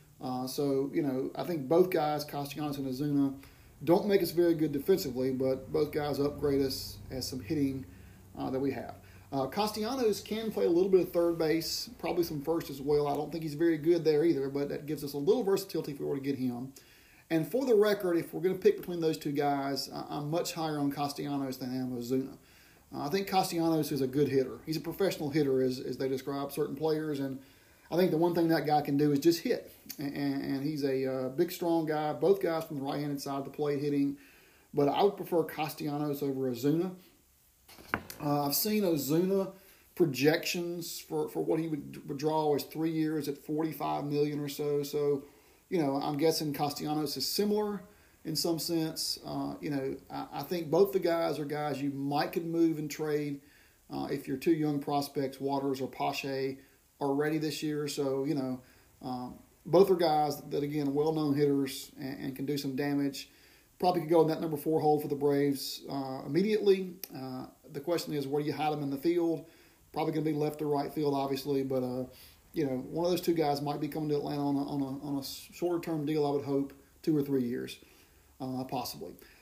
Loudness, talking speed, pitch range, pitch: -32 LUFS, 215 wpm, 140-160 Hz, 145 Hz